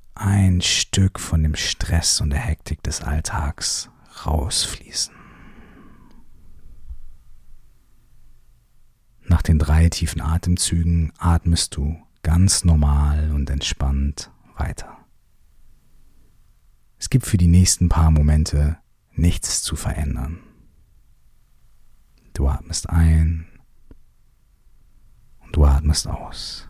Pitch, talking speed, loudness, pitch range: 80 Hz, 90 wpm, -20 LUFS, 75-85 Hz